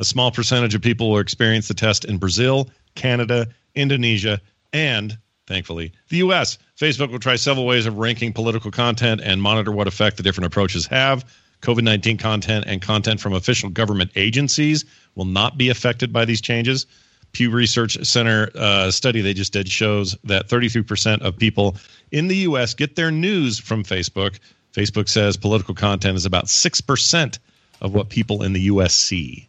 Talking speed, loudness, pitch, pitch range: 175 wpm, -19 LUFS, 110 Hz, 100-125 Hz